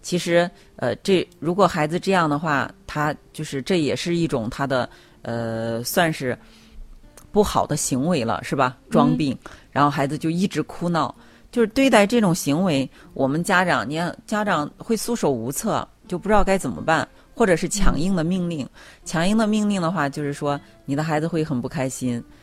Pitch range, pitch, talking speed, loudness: 140-190 Hz, 160 Hz, 265 characters per minute, -22 LUFS